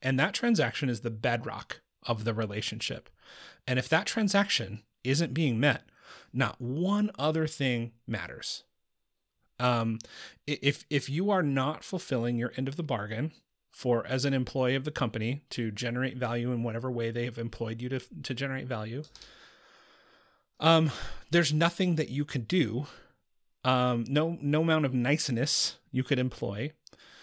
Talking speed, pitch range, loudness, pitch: 155 wpm, 120-150 Hz, -30 LUFS, 130 Hz